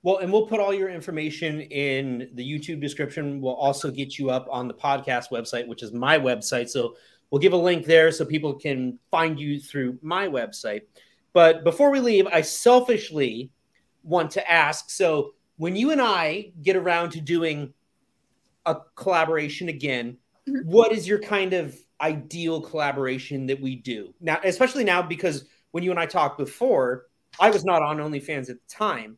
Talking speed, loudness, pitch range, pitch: 180 wpm, -23 LUFS, 140-185 Hz, 160 Hz